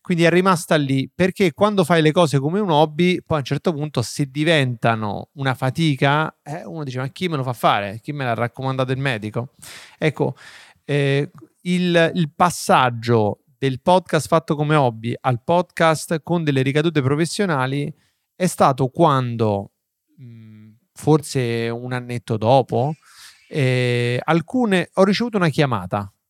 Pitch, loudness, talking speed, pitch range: 145 Hz, -20 LUFS, 150 wpm, 125-170 Hz